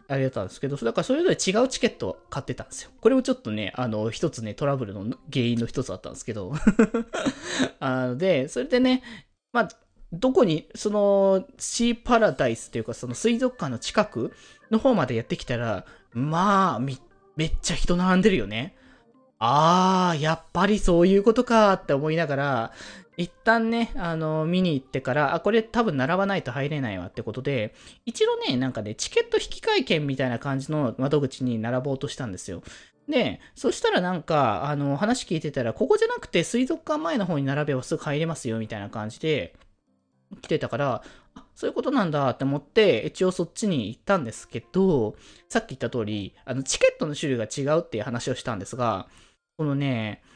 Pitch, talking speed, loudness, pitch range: 155 Hz, 385 characters per minute, -25 LUFS, 130-215 Hz